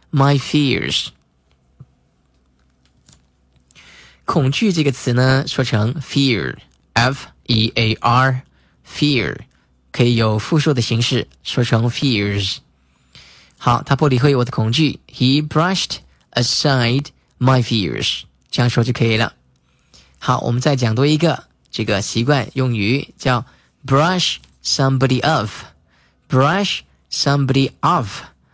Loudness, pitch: -17 LUFS, 120 Hz